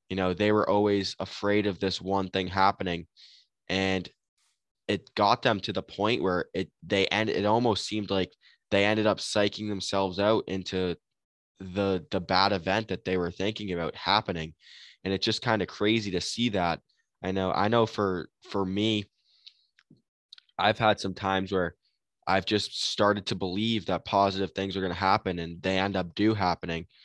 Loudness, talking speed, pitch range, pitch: -28 LUFS, 180 wpm, 95-105 Hz, 95 Hz